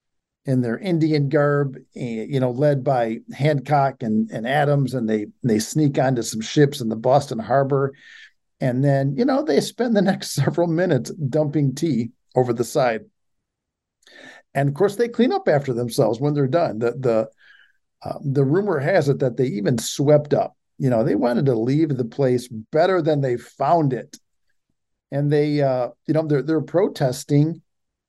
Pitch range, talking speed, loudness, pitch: 125-155 Hz, 175 wpm, -21 LUFS, 140 Hz